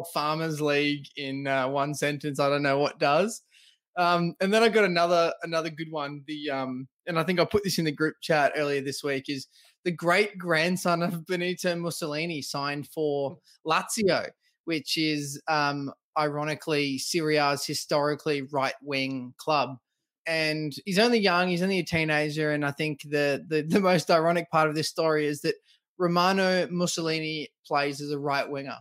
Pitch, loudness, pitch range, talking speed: 155 Hz, -27 LUFS, 145-170 Hz, 170 wpm